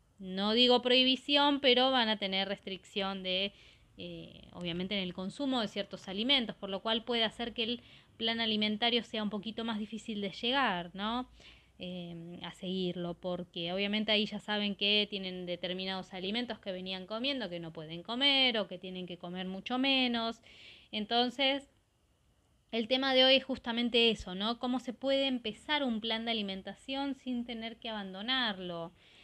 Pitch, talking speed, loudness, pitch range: 215 Hz, 165 wpm, -32 LUFS, 190-245 Hz